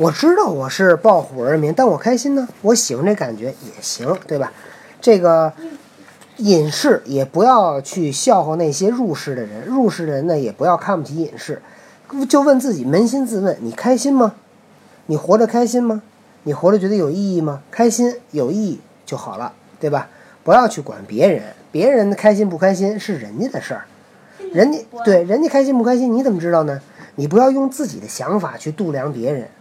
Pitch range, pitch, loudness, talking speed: 165-245 Hz, 205 Hz, -16 LUFS, 285 characters per minute